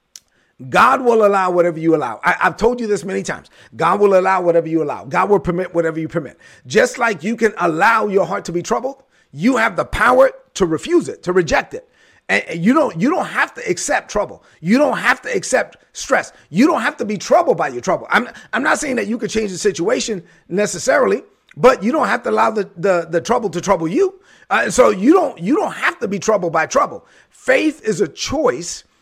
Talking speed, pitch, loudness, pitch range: 230 wpm, 205 Hz, -17 LUFS, 180-235 Hz